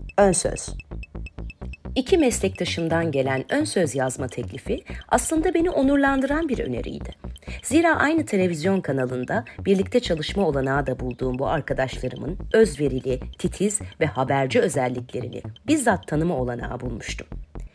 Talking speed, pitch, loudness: 110 wpm, 155 Hz, -23 LUFS